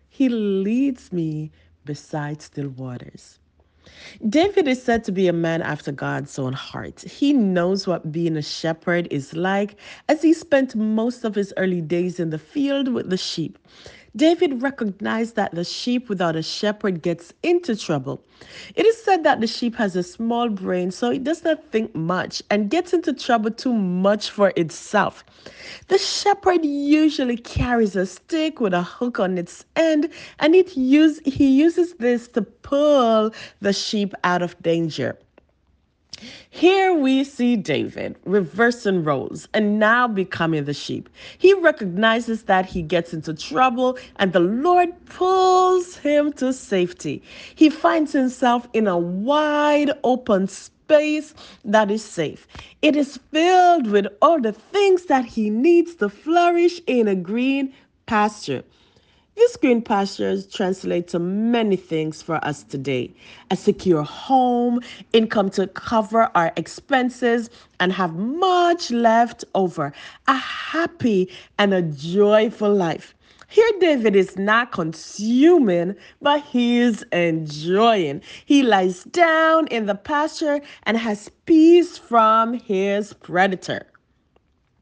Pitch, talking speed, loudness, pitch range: 220 Hz, 140 wpm, -20 LUFS, 180-285 Hz